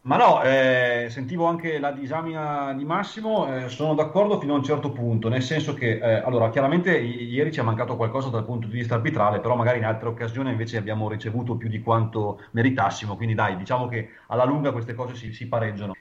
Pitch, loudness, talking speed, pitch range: 120 Hz, -24 LUFS, 210 wpm, 115-140 Hz